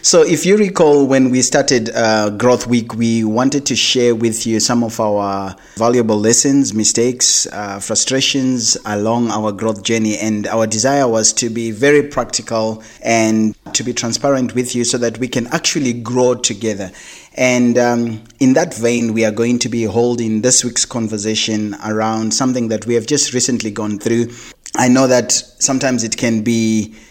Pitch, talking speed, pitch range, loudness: 115 Hz, 175 wpm, 110-125 Hz, -15 LUFS